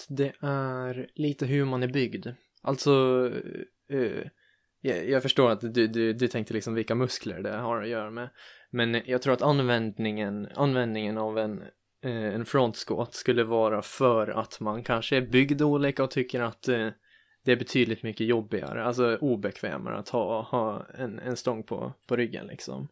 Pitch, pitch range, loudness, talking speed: 120 Hz, 115-130 Hz, -28 LUFS, 160 wpm